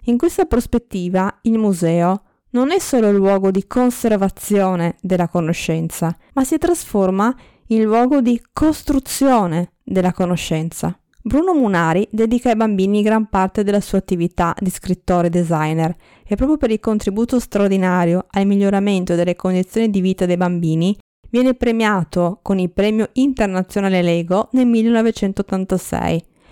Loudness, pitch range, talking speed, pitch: -17 LUFS, 180-230 Hz, 135 wpm, 200 Hz